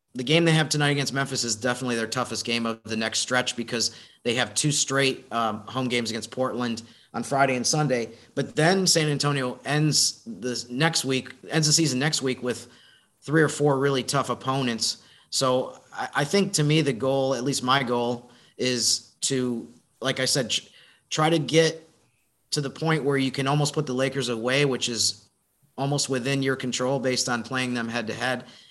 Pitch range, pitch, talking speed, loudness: 120-145 Hz, 130 Hz, 195 wpm, -24 LUFS